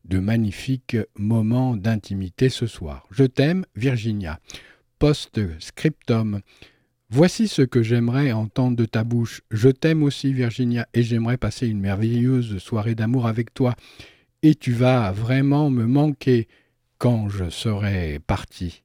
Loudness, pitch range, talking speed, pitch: -22 LUFS, 105-130 Hz, 130 wpm, 120 Hz